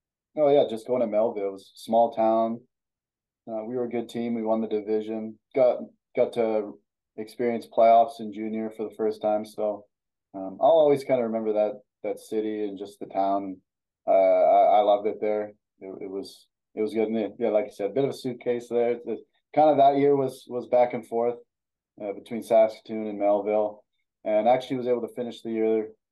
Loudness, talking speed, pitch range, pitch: -25 LUFS, 215 wpm, 105-120 Hz, 110 Hz